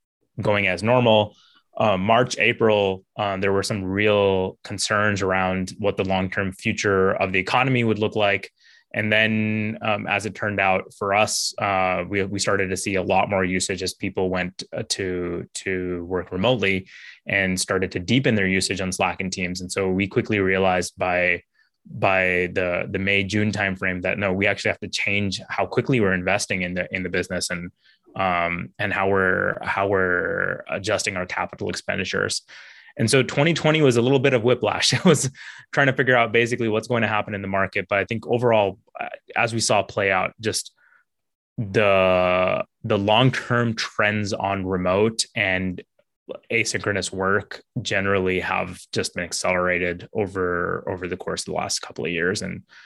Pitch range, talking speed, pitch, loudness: 95-110 Hz, 175 wpm, 100 Hz, -22 LUFS